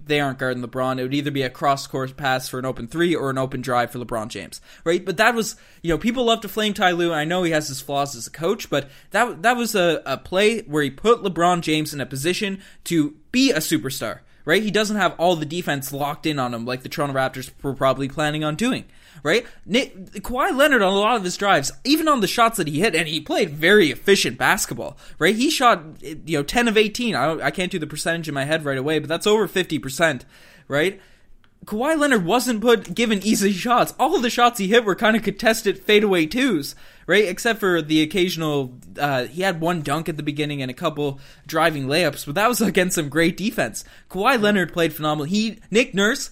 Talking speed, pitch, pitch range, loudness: 235 wpm, 170 Hz, 145-215 Hz, -21 LUFS